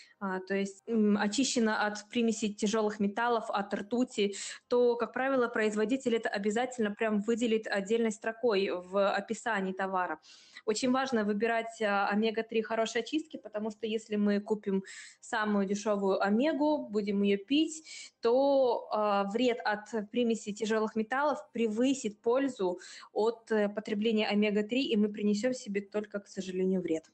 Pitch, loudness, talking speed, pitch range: 220 Hz, -31 LUFS, 135 wpm, 205-235 Hz